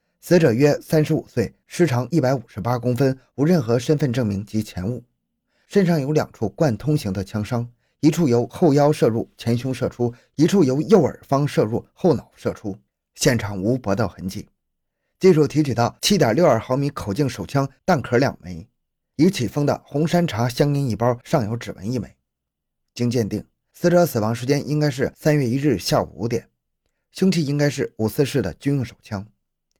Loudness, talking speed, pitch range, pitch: -21 LUFS, 275 characters per minute, 115-155 Hz, 130 Hz